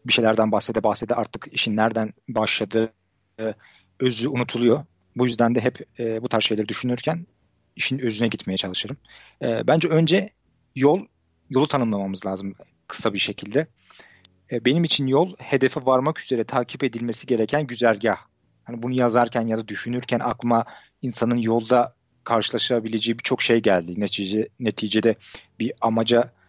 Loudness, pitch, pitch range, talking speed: -23 LUFS, 115 Hz, 110-125 Hz, 140 wpm